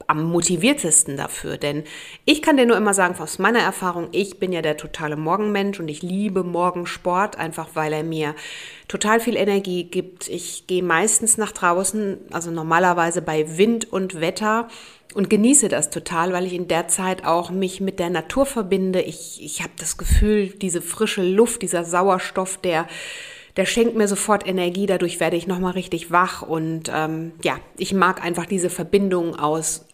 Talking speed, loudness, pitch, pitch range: 175 wpm, -21 LUFS, 180 Hz, 165-200 Hz